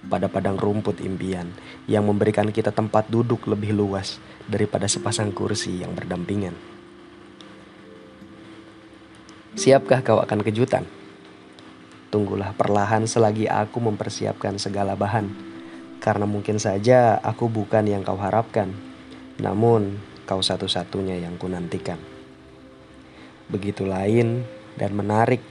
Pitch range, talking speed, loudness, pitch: 90-110 Hz, 105 wpm, -23 LUFS, 100 Hz